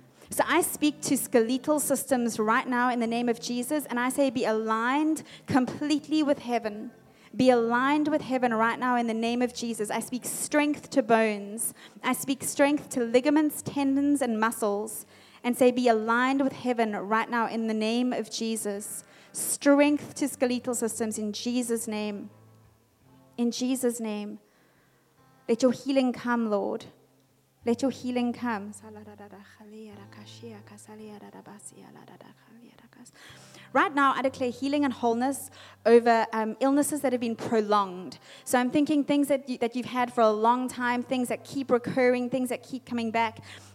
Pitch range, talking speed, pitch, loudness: 220-265 Hz, 155 wpm, 240 Hz, -27 LUFS